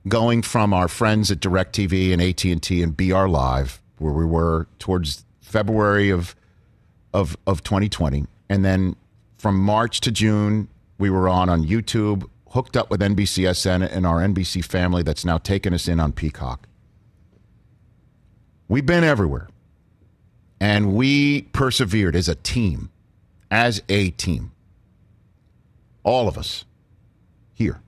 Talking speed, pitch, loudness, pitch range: 135 wpm, 95 Hz, -21 LUFS, 90-110 Hz